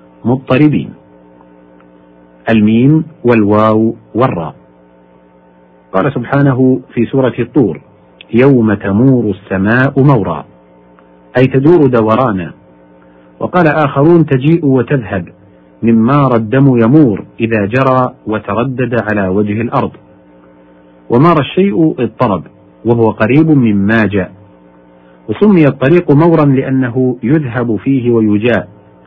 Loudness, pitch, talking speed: -11 LUFS, 115 Hz, 90 wpm